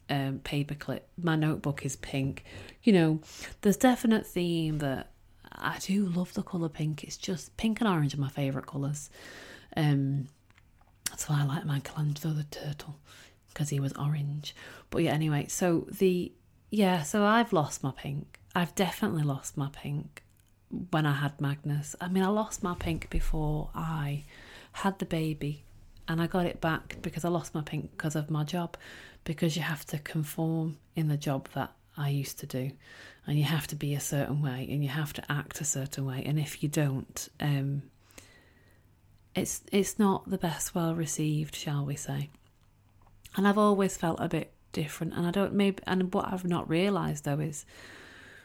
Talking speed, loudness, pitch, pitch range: 180 wpm, -31 LUFS, 150 Hz, 140-175 Hz